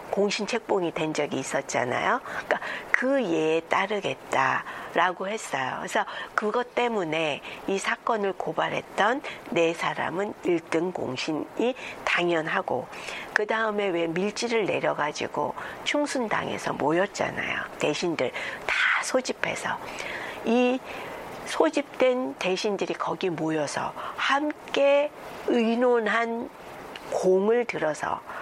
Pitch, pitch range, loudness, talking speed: 210 Hz, 170-245 Hz, -26 LUFS, 235 characters per minute